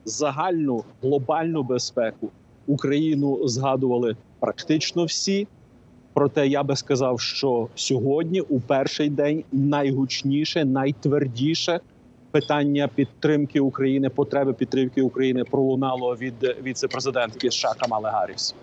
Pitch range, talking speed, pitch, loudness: 130-145 Hz, 95 wpm, 140 Hz, -23 LUFS